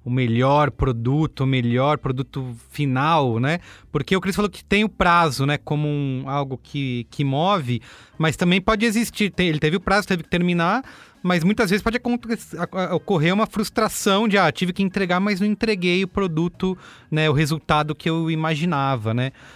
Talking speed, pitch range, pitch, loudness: 185 wpm, 140-195 Hz, 165 Hz, -21 LUFS